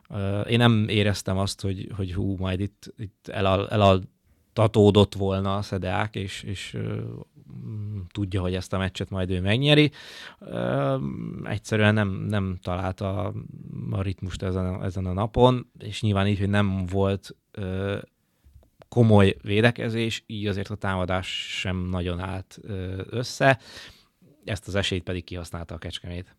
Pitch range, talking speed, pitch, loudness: 95-105 Hz, 130 wpm, 100 Hz, -25 LUFS